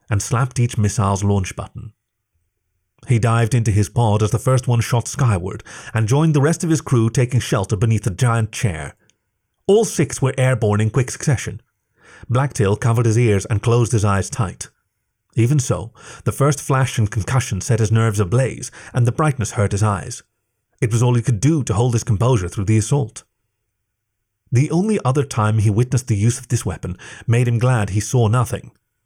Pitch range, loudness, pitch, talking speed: 105-125 Hz, -18 LUFS, 115 Hz, 190 wpm